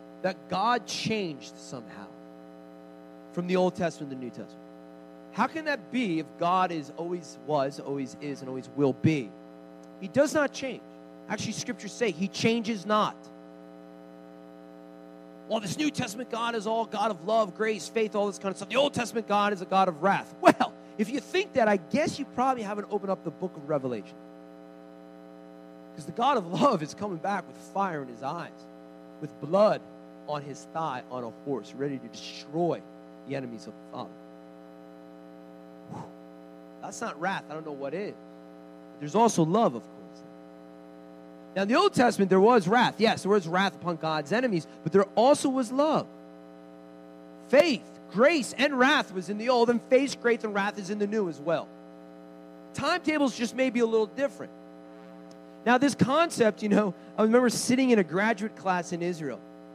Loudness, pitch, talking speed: -27 LUFS, 155 Hz, 185 wpm